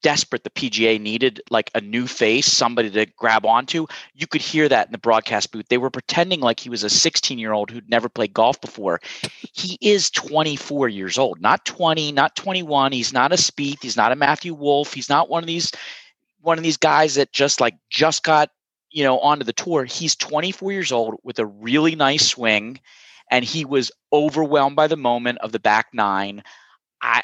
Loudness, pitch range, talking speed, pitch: -19 LUFS, 120-160 Hz, 205 wpm, 140 Hz